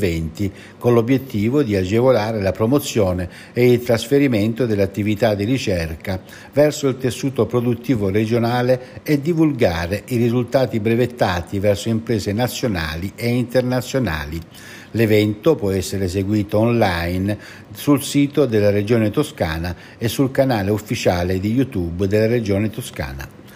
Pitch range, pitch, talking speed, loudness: 100-125 Hz, 110 Hz, 115 wpm, -19 LUFS